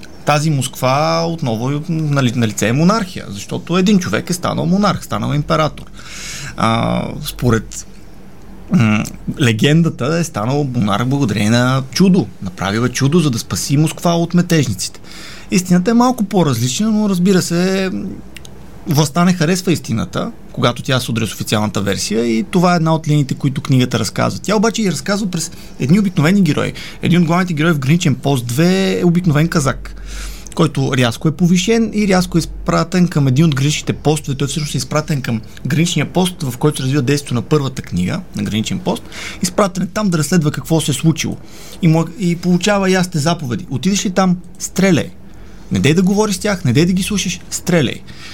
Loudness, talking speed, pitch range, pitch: -16 LUFS, 170 wpm, 130-180 Hz, 155 Hz